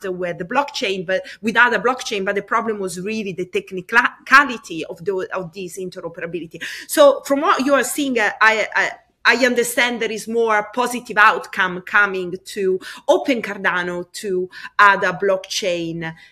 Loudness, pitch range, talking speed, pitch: -18 LUFS, 185-245 Hz, 155 wpm, 210 Hz